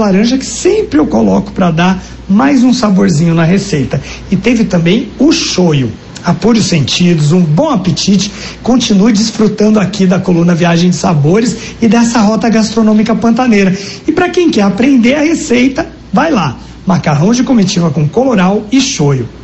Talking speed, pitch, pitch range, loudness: 160 wpm, 205 Hz, 175-235 Hz, -10 LUFS